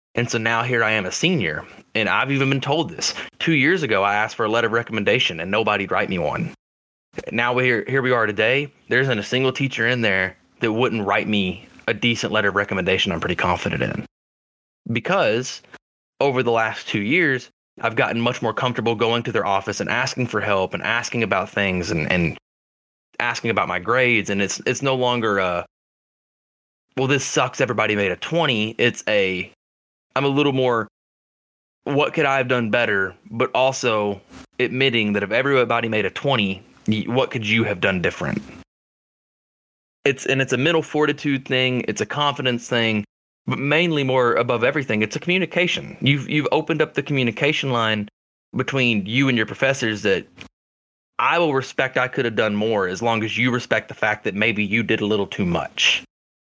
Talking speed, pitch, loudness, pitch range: 190 wpm, 120 Hz, -20 LUFS, 105-135 Hz